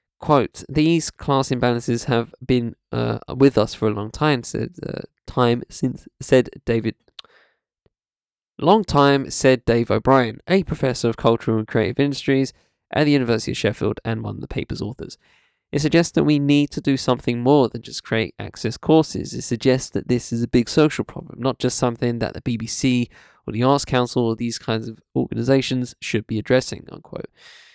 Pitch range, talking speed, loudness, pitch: 115-140 Hz, 180 wpm, -21 LUFS, 125 Hz